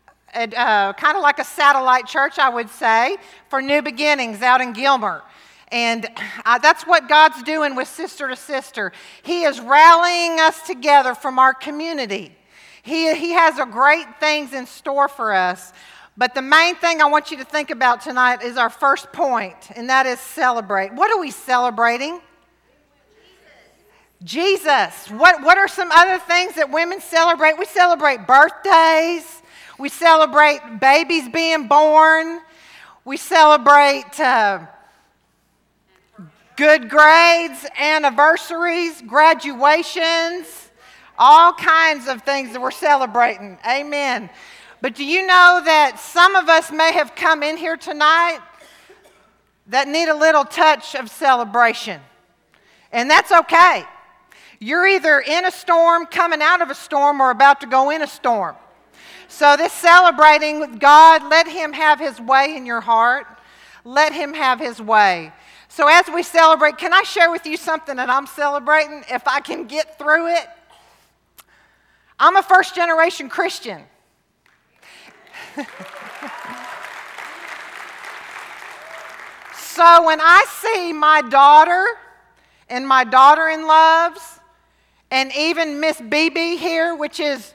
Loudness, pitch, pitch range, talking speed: -14 LUFS, 300 Hz, 265-330 Hz, 135 wpm